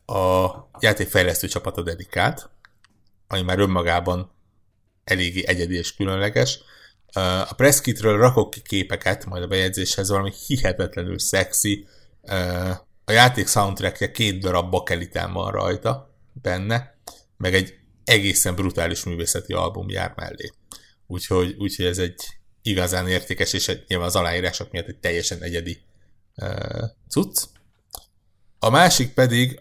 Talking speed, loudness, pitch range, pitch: 120 wpm, -21 LUFS, 90-105 Hz, 95 Hz